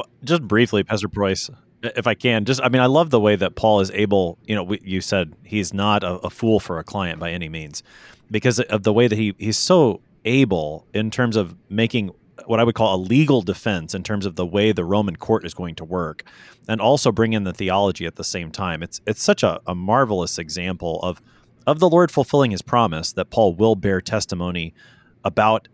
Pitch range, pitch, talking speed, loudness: 90-115 Hz, 105 Hz, 220 wpm, -20 LUFS